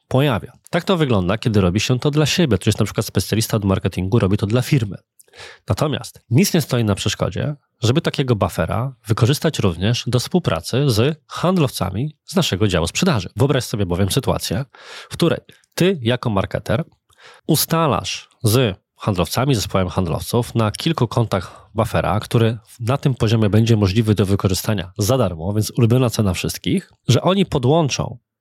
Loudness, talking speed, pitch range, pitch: -19 LUFS, 160 wpm, 100-140 Hz, 115 Hz